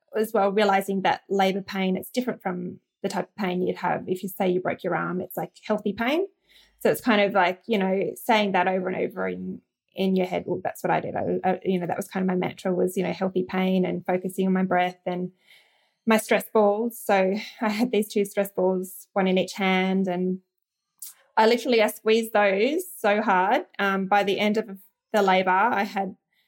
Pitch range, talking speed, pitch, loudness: 185-215 Hz, 225 wpm, 195 Hz, -24 LUFS